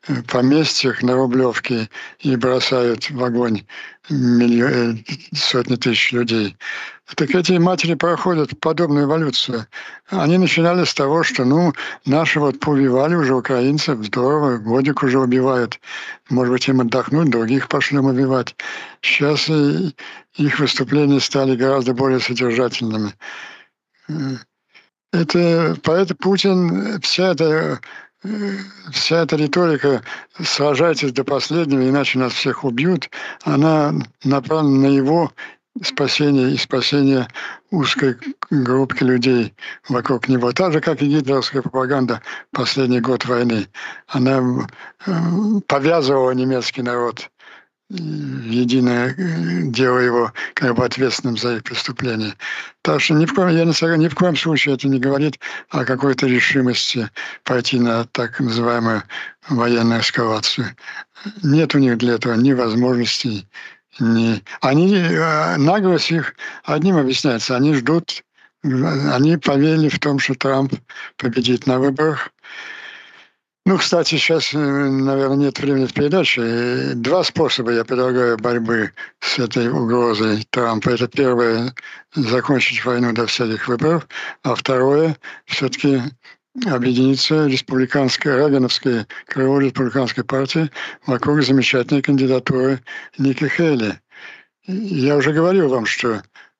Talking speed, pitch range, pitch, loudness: 115 wpm, 125-155 Hz, 135 Hz, -17 LUFS